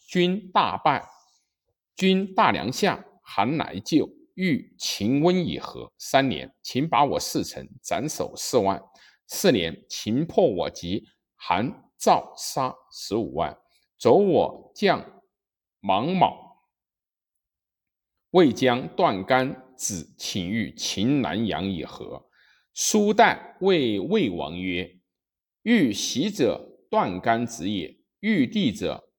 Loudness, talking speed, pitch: -24 LUFS, 145 characters per minute, 130 Hz